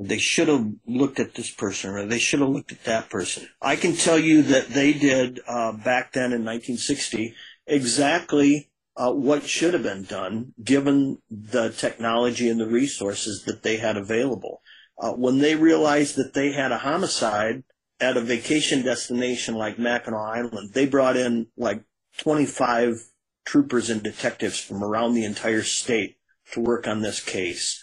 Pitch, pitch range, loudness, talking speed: 120 Hz, 115-140 Hz, -23 LUFS, 170 wpm